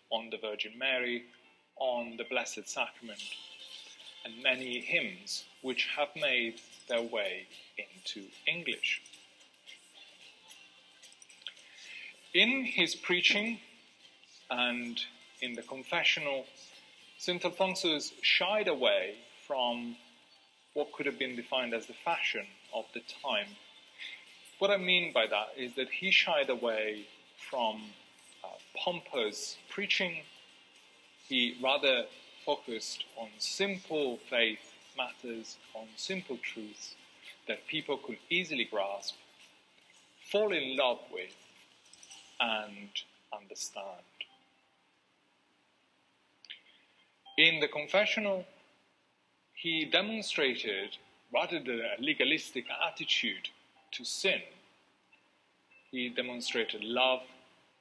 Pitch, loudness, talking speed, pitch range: 130 Hz, -32 LUFS, 90 wpm, 115-180 Hz